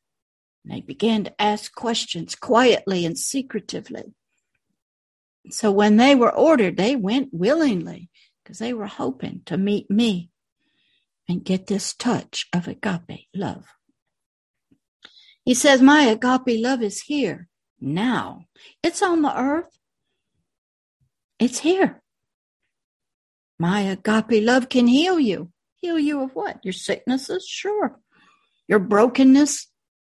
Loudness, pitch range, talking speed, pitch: -20 LUFS, 200-270 Hz, 115 wpm, 230 Hz